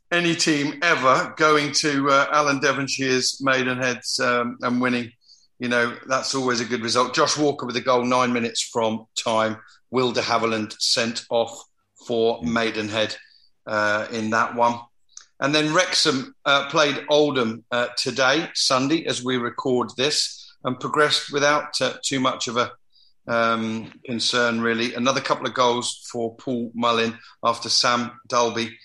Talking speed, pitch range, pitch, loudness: 150 wpm, 115-140 Hz, 125 Hz, -22 LUFS